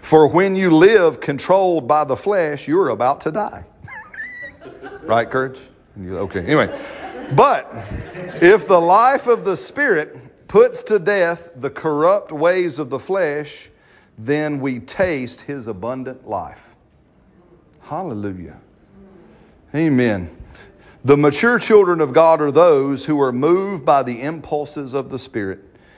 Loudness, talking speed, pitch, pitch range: -17 LUFS, 130 wpm, 150 Hz, 125-185 Hz